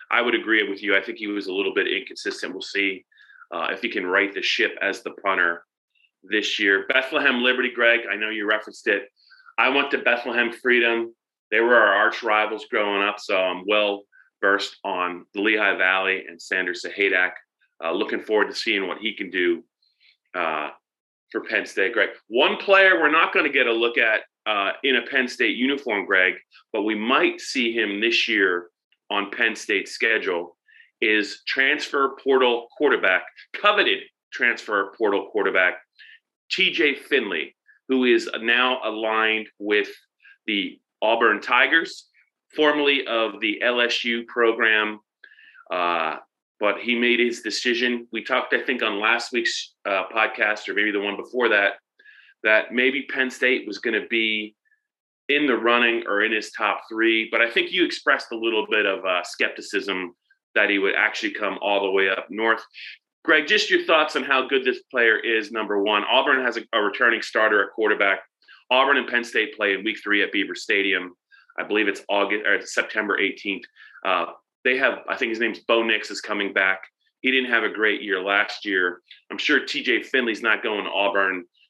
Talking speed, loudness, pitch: 180 wpm, -21 LUFS, 120 Hz